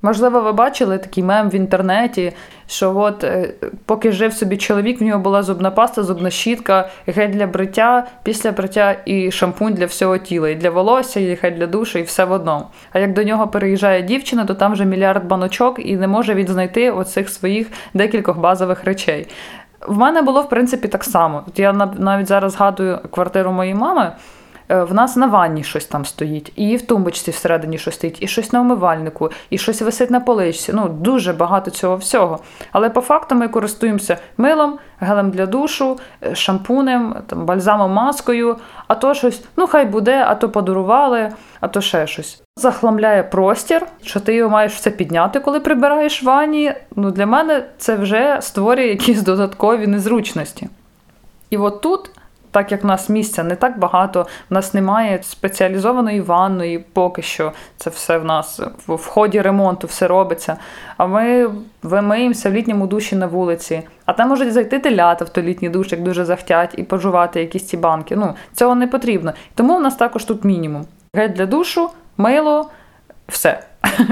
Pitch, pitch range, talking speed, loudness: 205 Hz, 185-235 Hz, 175 wpm, -16 LUFS